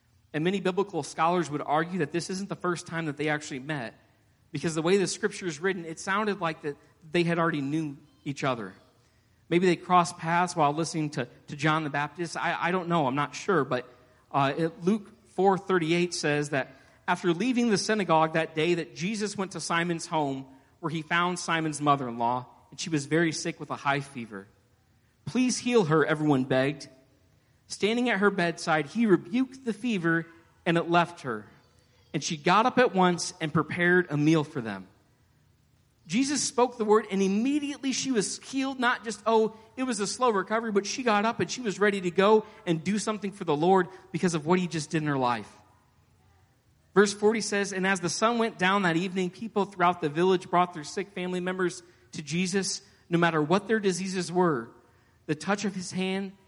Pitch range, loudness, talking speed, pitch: 150-195 Hz, -27 LUFS, 200 wpm, 170 Hz